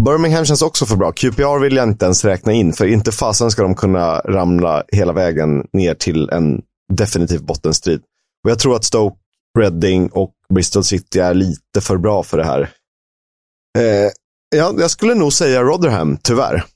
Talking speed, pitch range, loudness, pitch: 180 wpm, 90-125 Hz, -15 LUFS, 100 Hz